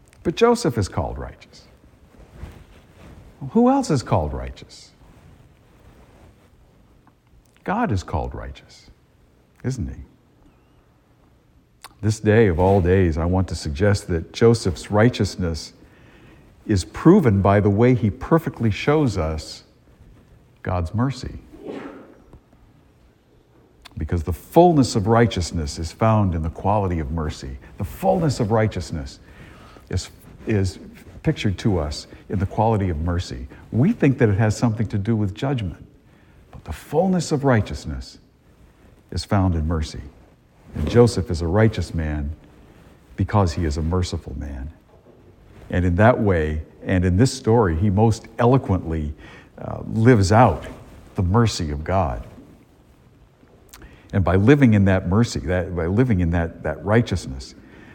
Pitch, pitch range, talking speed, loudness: 95 Hz, 80-115 Hz, 135 wpm, -20 LUFS